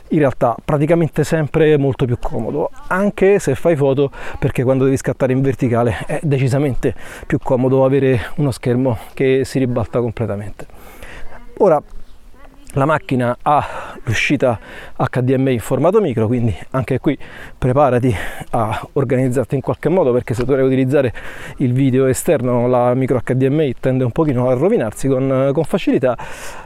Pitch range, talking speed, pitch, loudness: 125-145 Hz, 145 wpm, 135 Hz, -17 LUFS